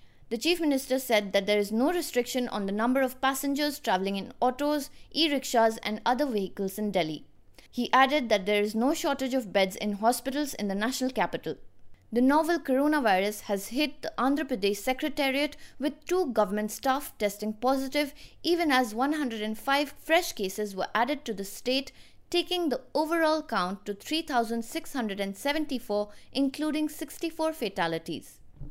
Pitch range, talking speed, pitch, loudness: 210-295 Hz, 155 wpm, 255 Hz, -28 LUFS